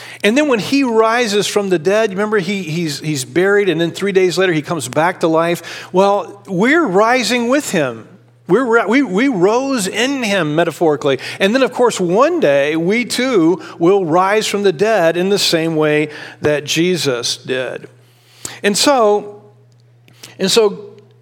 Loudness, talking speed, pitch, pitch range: -15 LUFS, 165 wpm, 190 Hz, 155-220 Hz